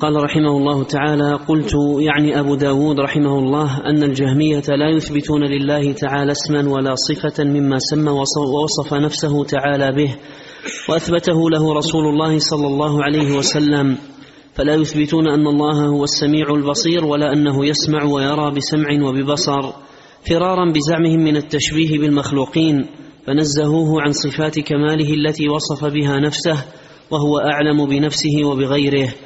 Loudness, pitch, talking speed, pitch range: -16 LUFS, 150 Hz, 130 wpm, 145-150 Hz